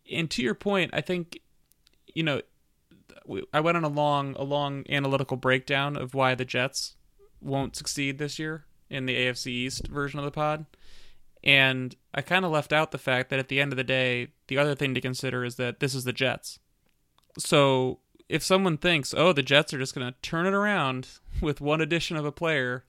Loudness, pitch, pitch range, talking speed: -26 LUFS, 140 Hz, 130-155 Hz, 205 wpm